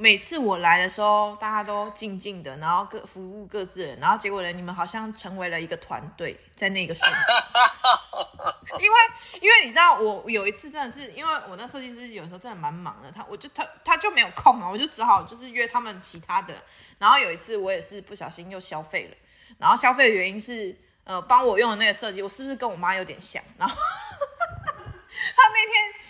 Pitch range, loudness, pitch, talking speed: 190-295 Hz, -21 LUFS, 215 Hz, 320 characters per minute